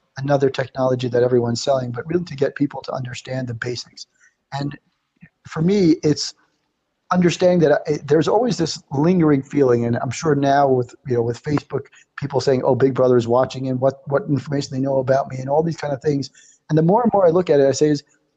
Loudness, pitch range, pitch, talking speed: -19 LUFS, 130-155 Hz, 140 Hz, 225 wpm